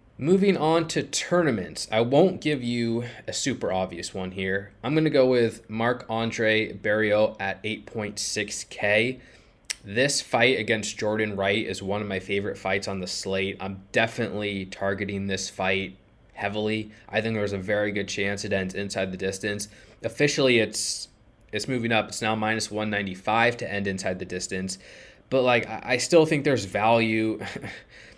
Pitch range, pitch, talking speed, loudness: 100-115 Hz, 105 Hz, 160 wpm, -25 LUFS